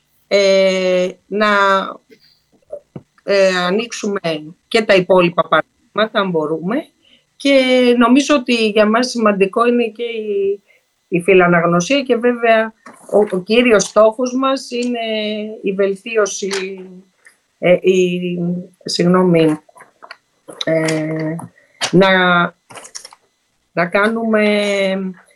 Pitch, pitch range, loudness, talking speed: 200 Hz, 180-230 Hz, -15 LUFS, 90 wpm